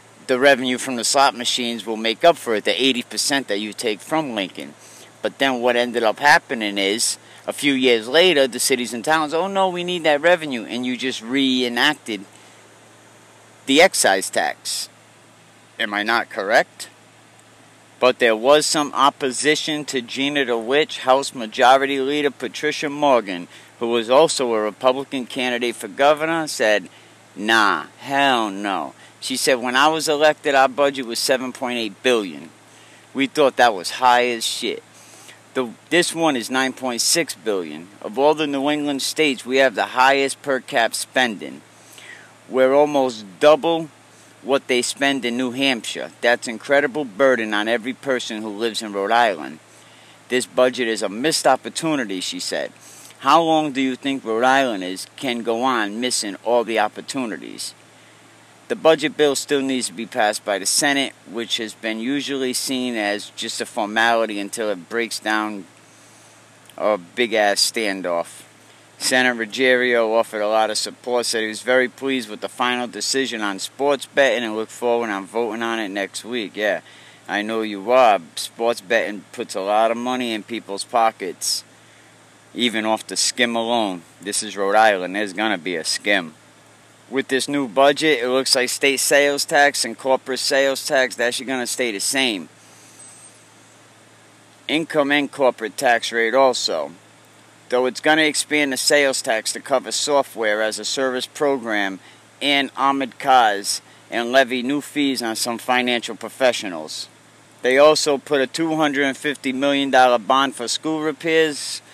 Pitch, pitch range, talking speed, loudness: 125 Hz, 115-140 Hz, 165 wpm, -19 LUFS